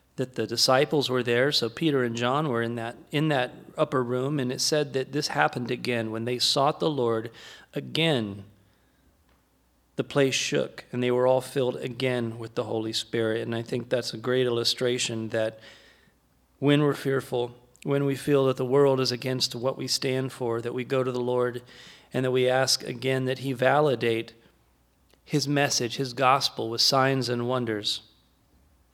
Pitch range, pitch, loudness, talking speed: 115-135 Hz, 125 Hz, -26 LUFS, 180 wpm